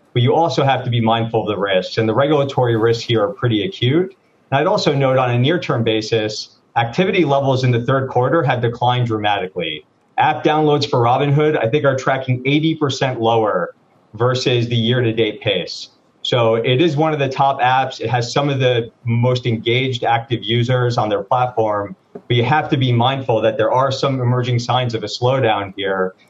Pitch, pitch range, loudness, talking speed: 125 Hz, 115-140 Hz, -17 LUFS, 200 wpm